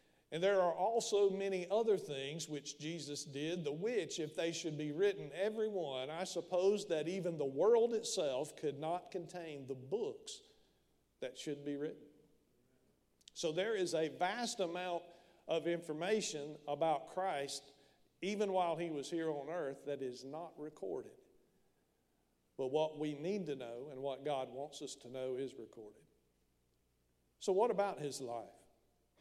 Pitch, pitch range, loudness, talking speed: 155 Hz, 140-185 Hz, -39 LUFS, 155 wpm